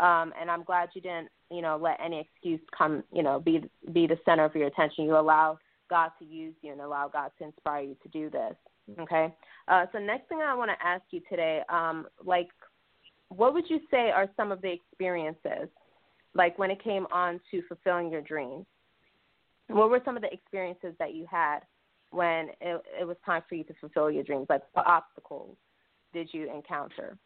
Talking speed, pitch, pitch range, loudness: 205 wpm, 170 Hz, 160-185 Hz, -29 LUFS